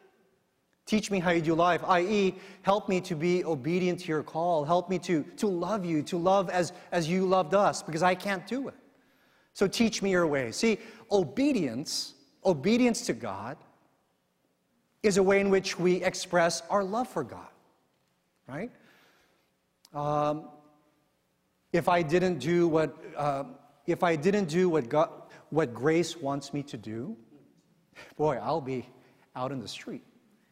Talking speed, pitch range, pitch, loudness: 160 wpm, 150-195 Hz, 180 Hz, -28 LUFS